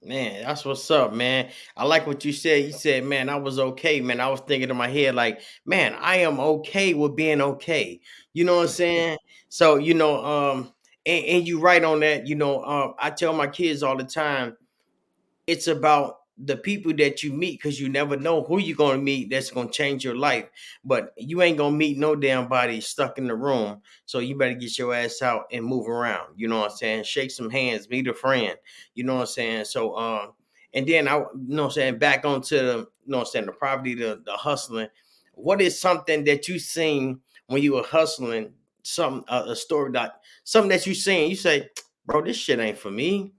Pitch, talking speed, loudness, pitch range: 145 Hz, 230 wpm, -23 LUFS, 130-160 Hz